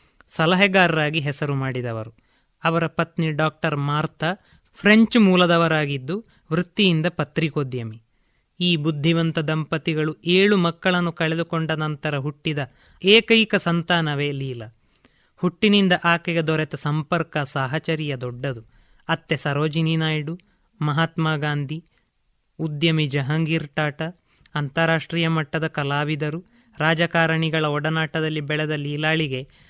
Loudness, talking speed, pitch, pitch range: -21 LUFS, 85 wpm, 160 Hz, 150-170 Hz